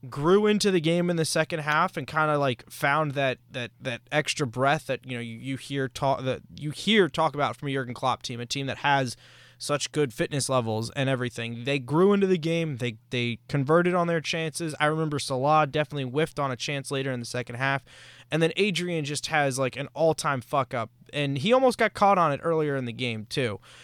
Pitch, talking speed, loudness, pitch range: 140 Hz, 230 wpm, -26 LUFS, 130-160 Hz